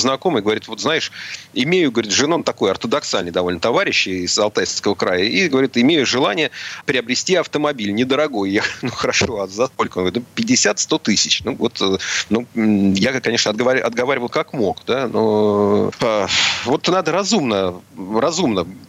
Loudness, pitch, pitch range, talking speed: -17 LUFS, 110 Hz, 100-130 Hz, 145 wpm